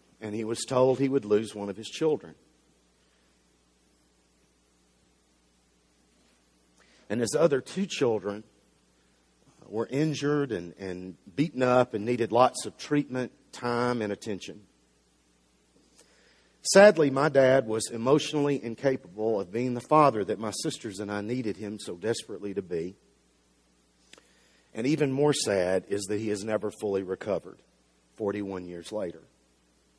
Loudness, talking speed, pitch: -27 LUFS, 130 wpm, 100 Hz